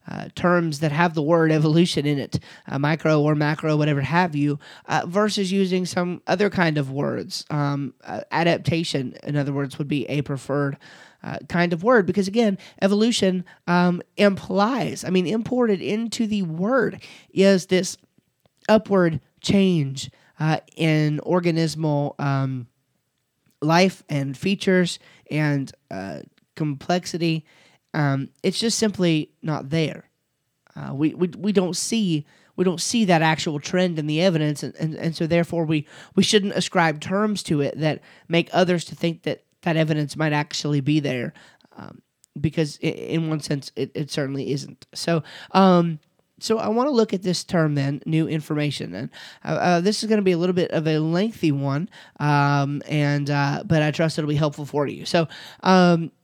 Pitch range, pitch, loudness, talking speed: 150-185 Hz, 165 Hz, -22 LUFS, 170 wpm